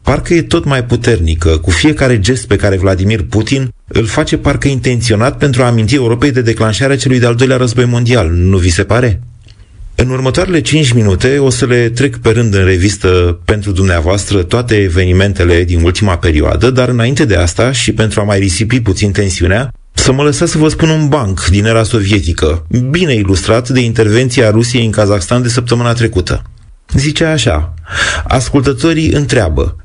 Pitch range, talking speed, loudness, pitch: 95-130 Hz, 175 wpm, -11 LUFS, 115 Hz